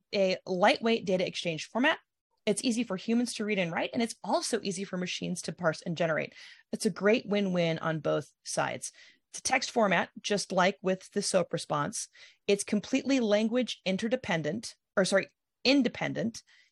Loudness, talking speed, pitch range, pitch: -30 LUFS, 170 wpm, 185-230 Hz, 205 Hz